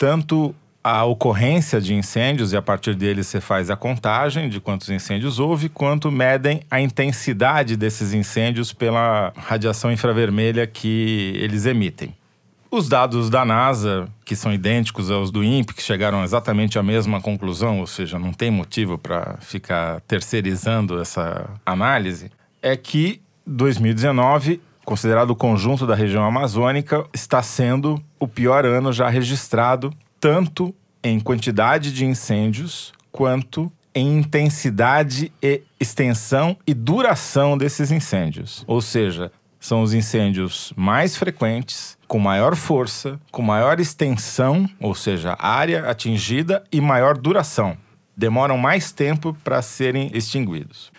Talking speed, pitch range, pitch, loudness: 130 wpm, 105-140 Hz, 120 Hz, -20 LUFS